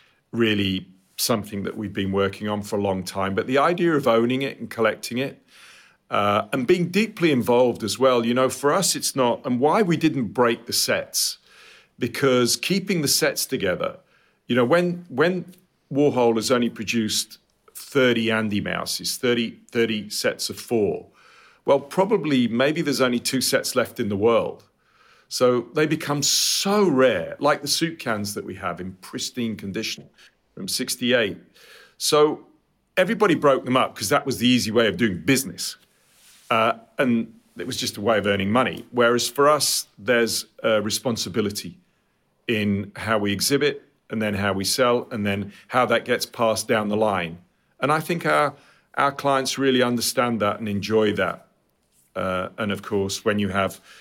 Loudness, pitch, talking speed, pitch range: -22 LUFS, 120 Hz, 175 wpm, 105-140 Hz